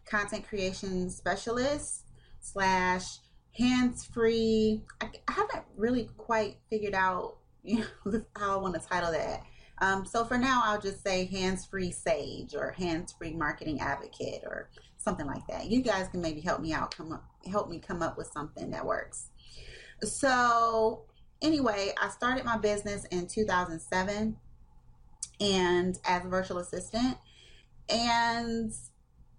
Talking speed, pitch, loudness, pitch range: 150 wpm, 205 Hz, -31 LUFS, 185-230 Hz